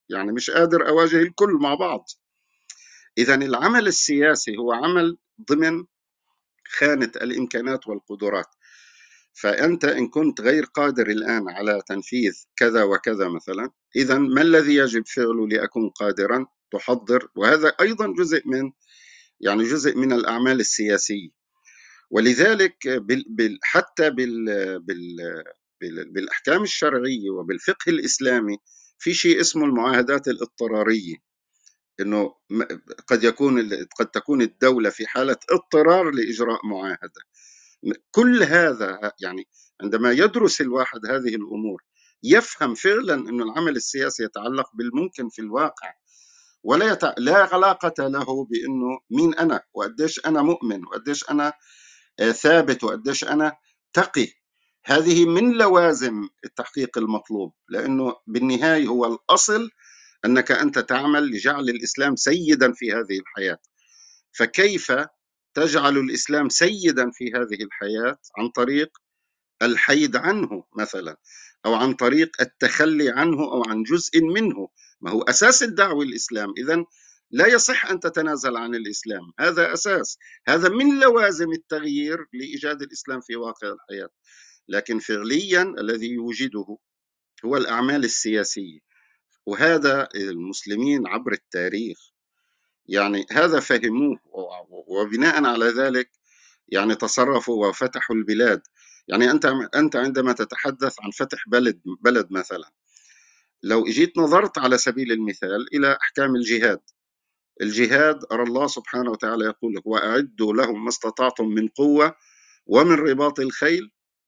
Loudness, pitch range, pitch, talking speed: -21 LUFS, 115-160 Hz, 130 Hz, 115 wpm